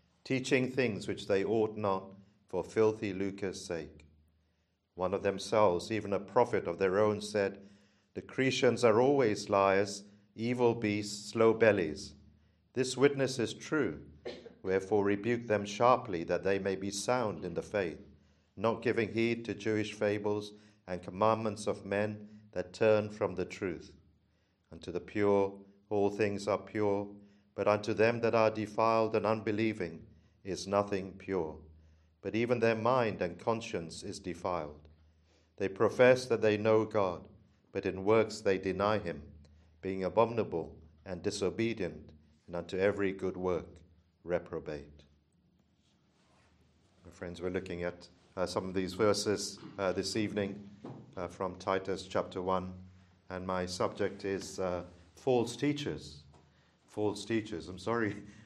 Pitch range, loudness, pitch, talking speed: 90-105 Hz, -33 LUFS, 100 Hz, 140 wpm